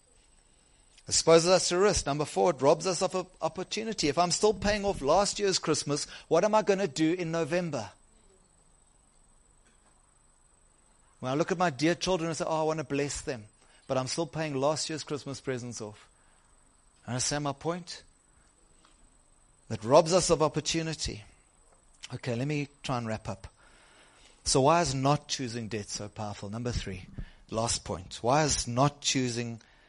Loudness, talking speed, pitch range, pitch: -29 LUFS, 170 wpm, 115-170 Hz, 145 Hz